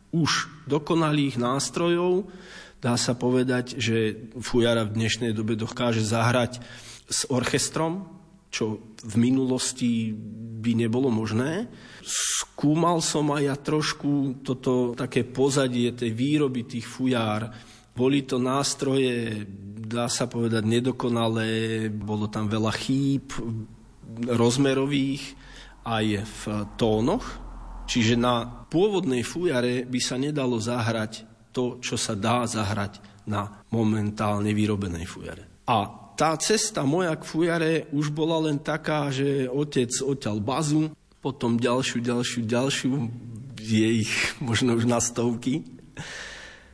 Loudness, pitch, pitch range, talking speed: -25 LUFS, 120 Hz, 115-140 Hz, 115 wpm